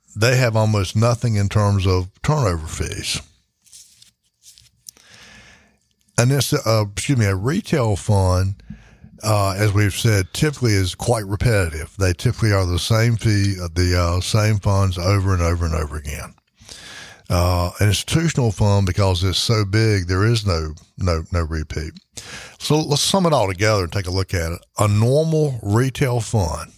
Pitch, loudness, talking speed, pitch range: 100 Hz, -19 LUFS, 160 wpm, 90-115 Hz